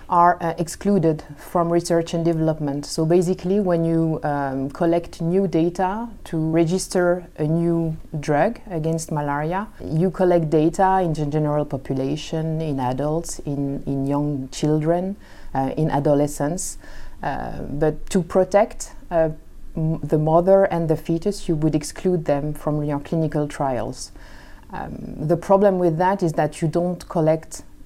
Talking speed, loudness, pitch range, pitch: 140 wpm, -22 LUFS, 150-175 Hz, 160 Hz